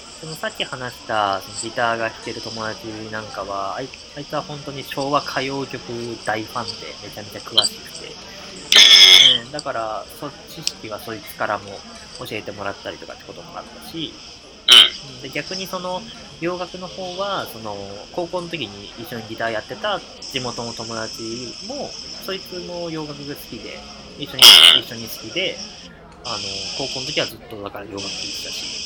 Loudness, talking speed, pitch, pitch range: -15 LUFS, 310 characters per minute, 120 Hz, 110-155 Hz